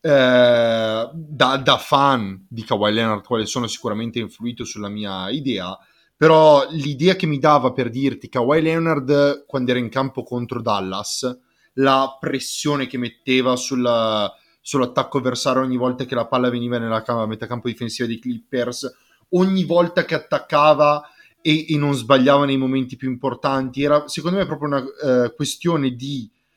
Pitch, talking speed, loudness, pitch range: 130 Hz, 155 wpm, -19 LUFS, 120-145 Hz